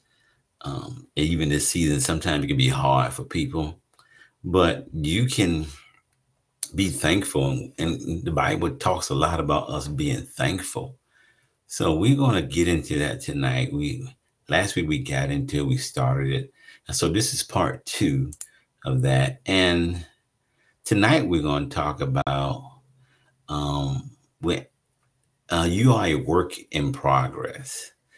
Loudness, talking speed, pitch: -23 LUFS, 145 wpm, 115 Hz